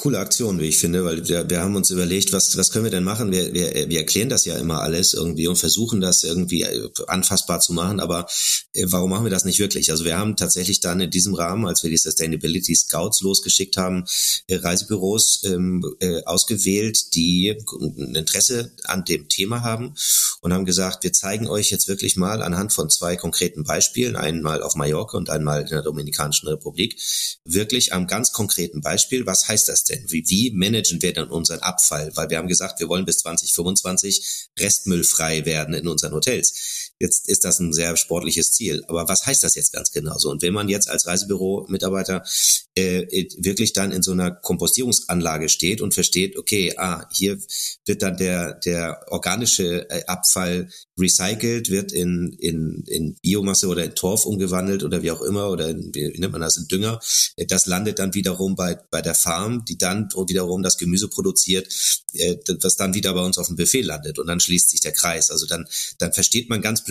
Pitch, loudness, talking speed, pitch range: 90 Hz, -19 LUFS, 190 wpm, 85-100 Hz